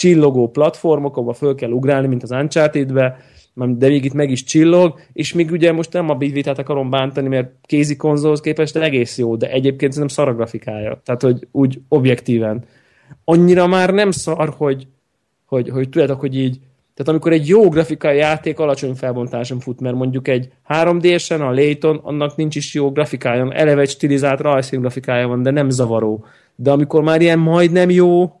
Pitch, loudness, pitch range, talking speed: 140 Hz, -16 LUFS, 130-155 Hz, 185 wpm